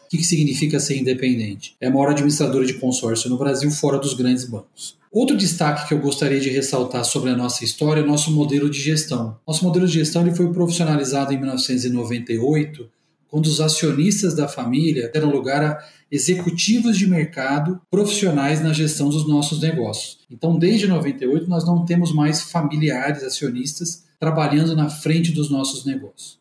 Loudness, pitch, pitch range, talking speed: -20 LUFS, 150 Hz, 135-160 Hz, 170 wpm